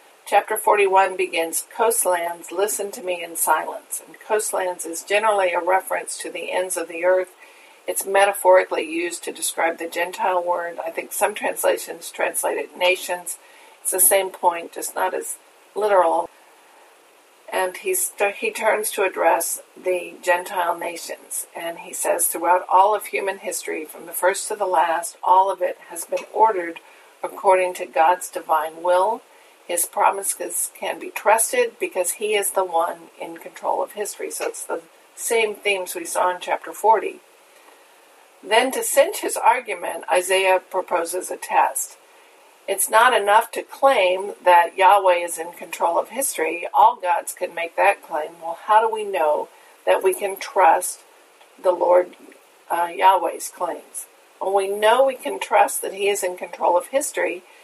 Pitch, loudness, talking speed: 195 Hz, -21 LUFS, 165 wpm